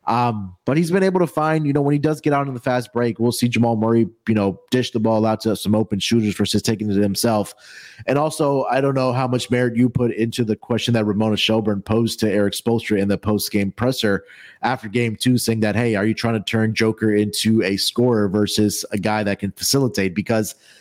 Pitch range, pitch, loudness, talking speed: 105-125 Hz, 110 Hz, -20 LUFS, 240 wpm